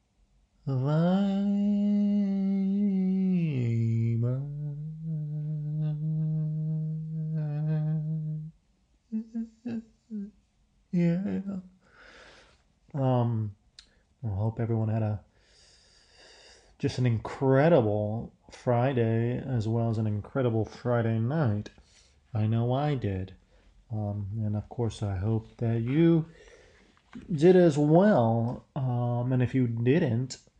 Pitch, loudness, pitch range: 135 Hz, -28 LUFS, 115-165 Hz